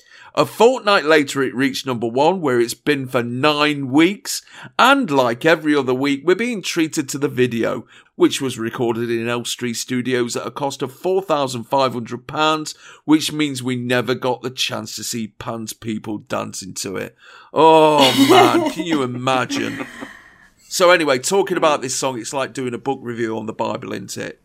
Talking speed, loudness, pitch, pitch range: 175 wpm, -18 LUFS, 135 Hz, 120-155 Hz